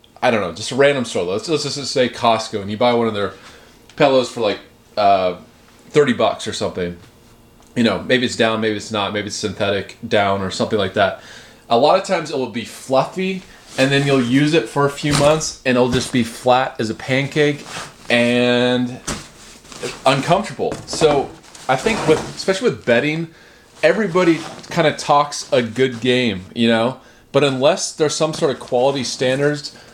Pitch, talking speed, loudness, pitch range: 125 Hz, 185 wpm, -18 LUFS, 115-145 Hz